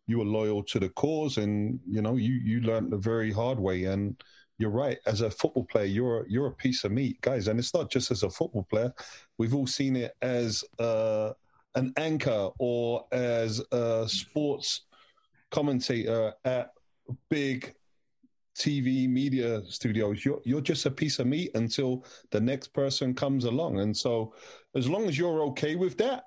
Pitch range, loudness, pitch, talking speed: 110-140 Hz, -29 LUFS, 125 Hz, 180 wpm